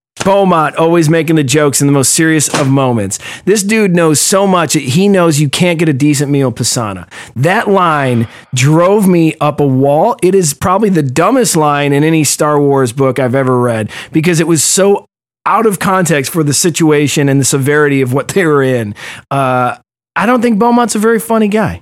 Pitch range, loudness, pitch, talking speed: 140-185 Hz, -10 LUFS, 155 Hz, 205 wpm